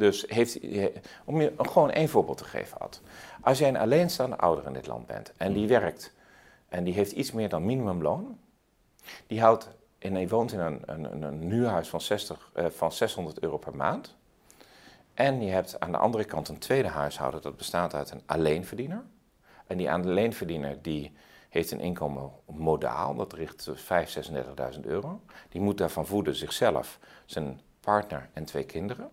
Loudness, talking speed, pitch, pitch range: -29 LUFS, 165 wpm, 85 Hz, 75-105 Hz